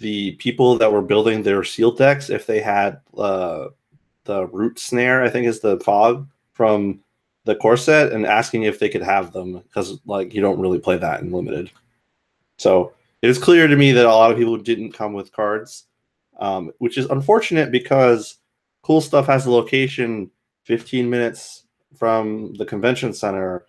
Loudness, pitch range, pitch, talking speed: -18 LUFS, 105-130 Hz, 115 Hz, 175 wpm